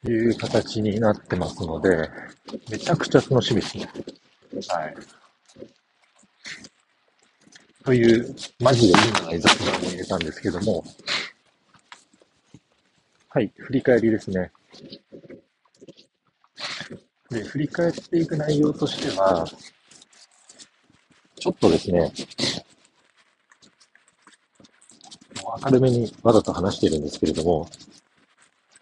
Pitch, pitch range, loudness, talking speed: 115 Hz, 110-140 Hz, -22 LUFS, 200 characters per minute